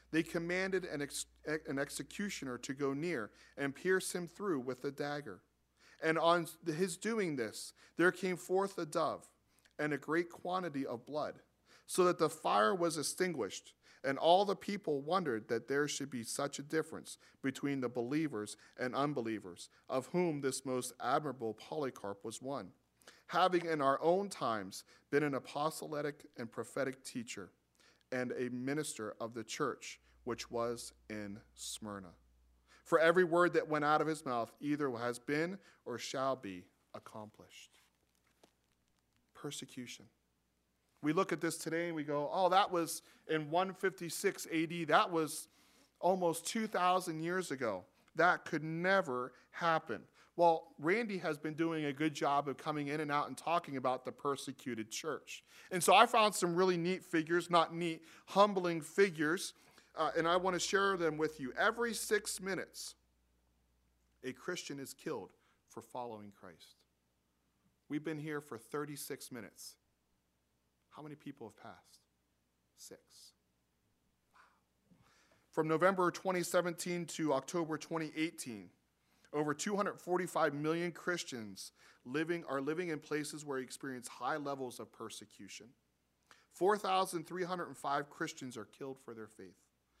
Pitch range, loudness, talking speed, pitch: 115-170 Hz, -36 LUFS, 145 wpm, 150 Hz